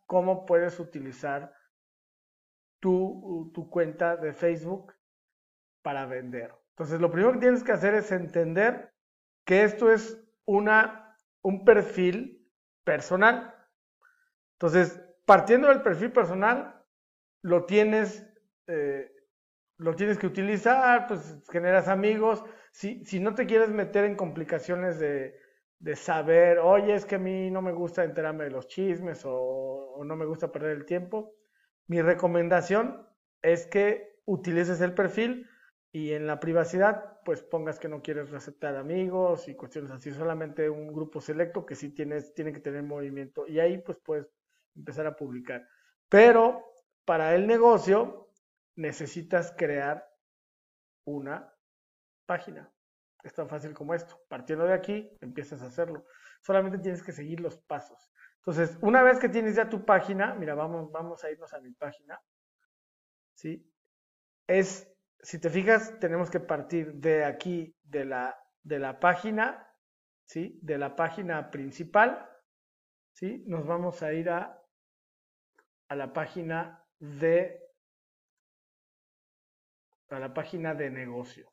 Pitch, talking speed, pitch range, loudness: 175 Hz, 140 wpm, 155-205 Hz, -27 LUFS